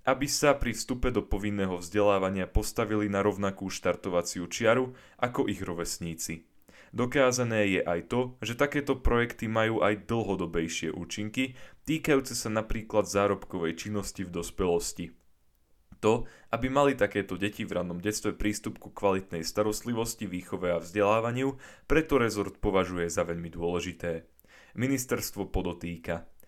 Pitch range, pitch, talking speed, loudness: 90-115 Hz, 105 Hz, 125 wpm, -30 LUFS